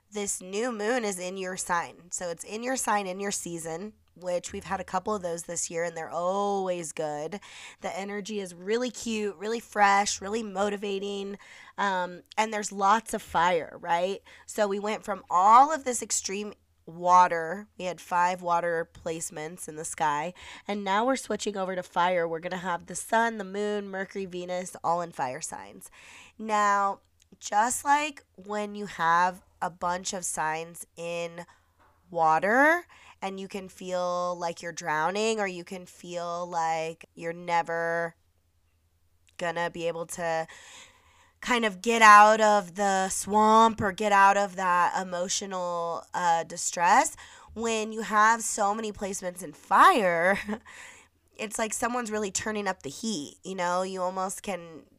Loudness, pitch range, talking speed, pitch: -27 LUFS, 170-210 Hz, 160 wpm, 190 Hz